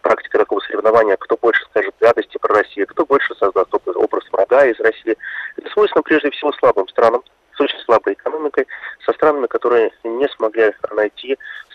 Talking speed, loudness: 165 wpm, -17 LUFS